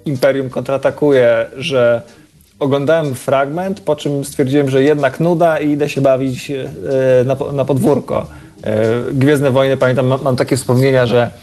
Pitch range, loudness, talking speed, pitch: 130-145 Hz, -14 LUFS, 125 wpm, 135 Hz